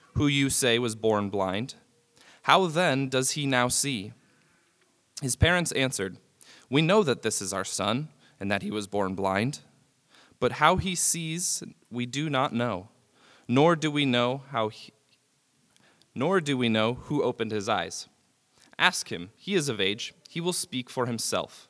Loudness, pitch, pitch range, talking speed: -26 LUFS, 125 Hz, 110-150 Hz, 170 wpm